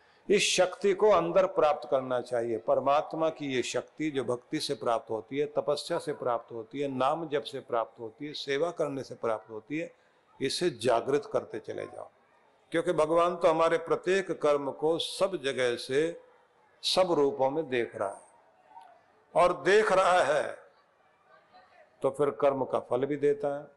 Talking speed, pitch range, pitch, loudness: 170 wpm, 135-180 Hz, 150 Hz, -29 LUFS